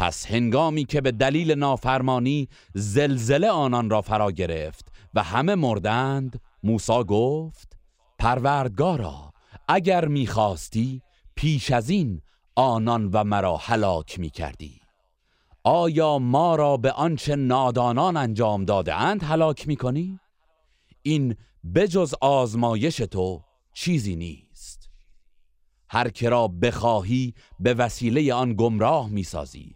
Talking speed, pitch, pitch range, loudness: 115 wpm, 120 Hz, 105-145 Hz, -23 LUFS